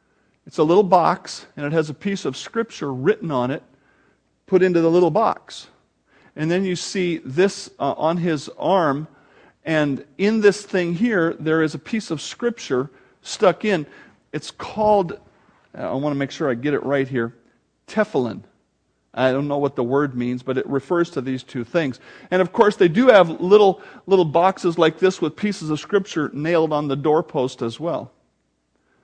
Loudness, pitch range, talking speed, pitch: -20 LUFS, 140-190 Hz, 185 wpm, 160 Hz